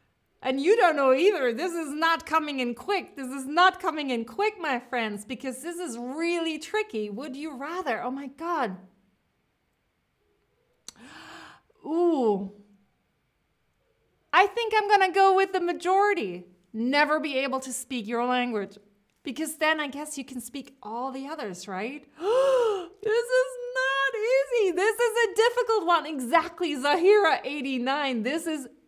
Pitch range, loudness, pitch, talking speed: 255-375 Hz, -26 LUFS, 300 Hz, 150 wpm